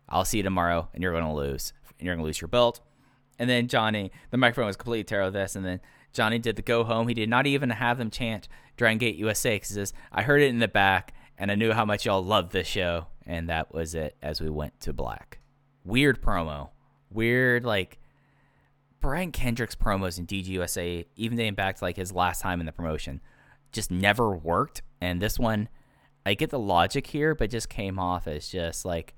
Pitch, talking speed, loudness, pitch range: 105 Hz, 215 wpm, -27 LUFS, 90-120 Hz